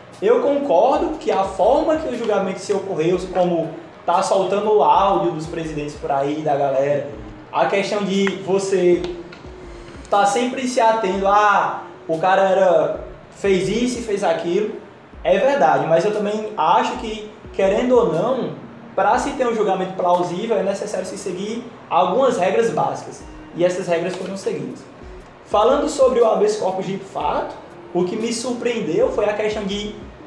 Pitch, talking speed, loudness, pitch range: 195 Hz, 160 wpm, -19 LUFS, 175-220 Hz